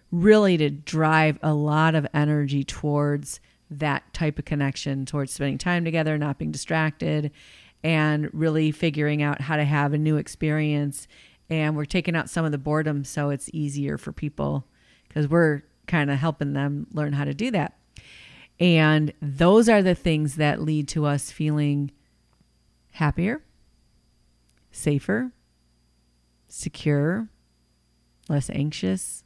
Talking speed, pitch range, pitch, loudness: 140 wpm, 140-155 Hz, 150 Hz, -24 LUFS